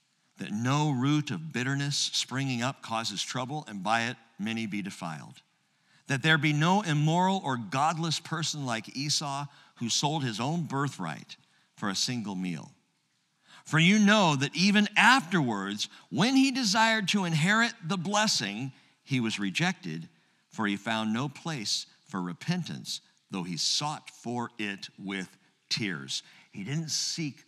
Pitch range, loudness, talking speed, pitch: 115-165 Hz, -28 LUFS, 145 wpm, 145 Hz